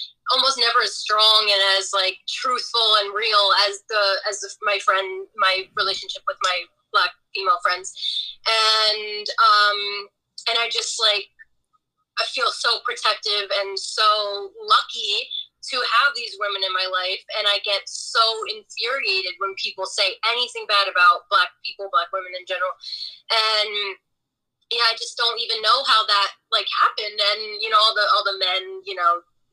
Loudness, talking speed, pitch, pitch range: -20 LUFS, 165 wpm, 210 Hz, 195-230 Hz